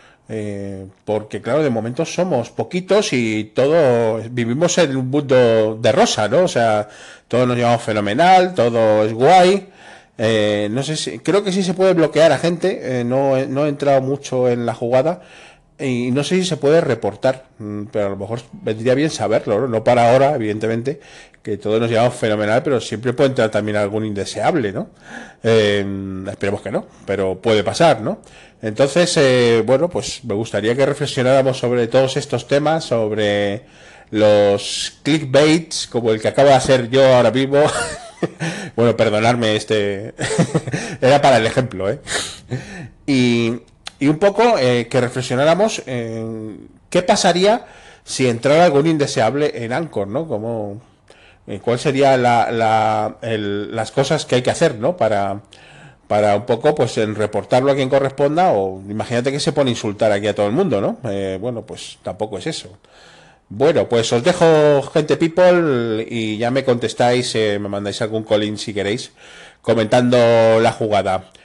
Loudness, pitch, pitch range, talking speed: -17 LUFS, 120 Hz, 110-140 Hz, 165 wpm